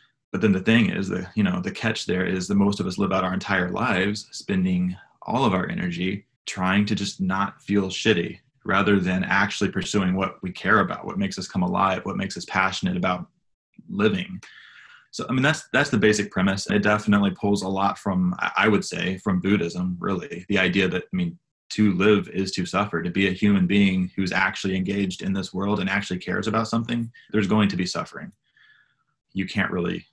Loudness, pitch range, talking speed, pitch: -23 LUFS, 95-105 Hz, 210 wpm, 100 Hz